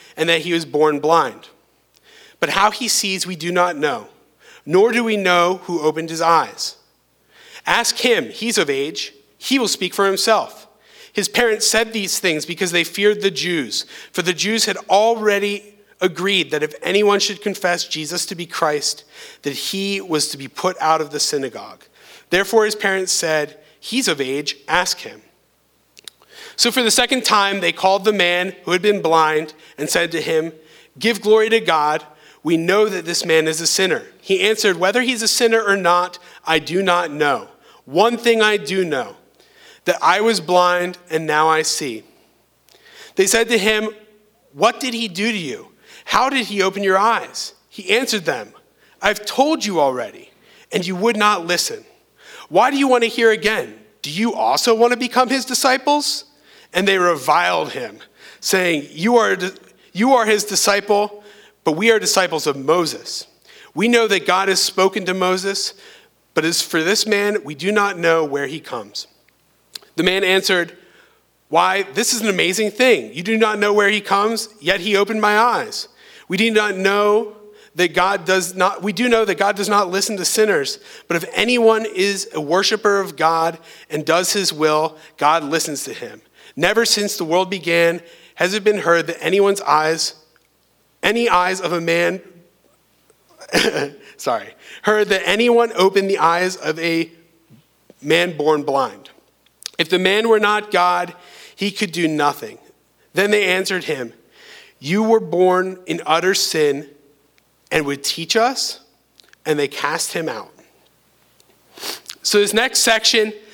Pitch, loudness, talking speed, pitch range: 195 Hz, -17 LUFS, 175 wpm, 170-215 Hz